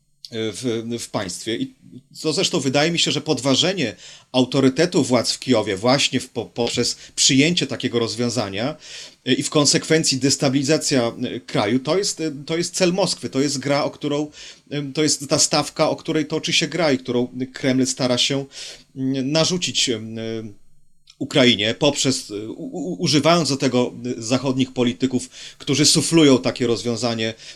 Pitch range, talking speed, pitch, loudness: 125-155 Hz, 140 wpm, 135 Hz, -20 LUFS